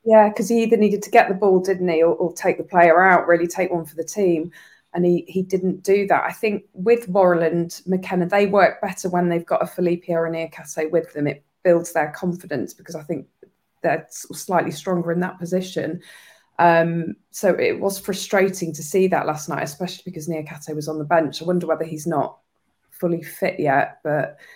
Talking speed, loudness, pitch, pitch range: 210 wpm, -20 LUFS, 175 Hz, 165-190 Hz